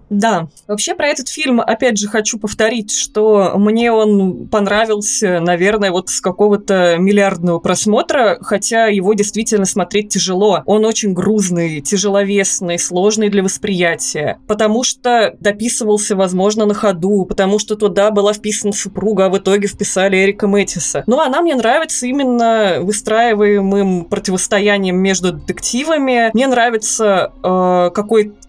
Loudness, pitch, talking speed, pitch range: -14 LUFS, 205 Hz, 130 wpm, 195-220 Hz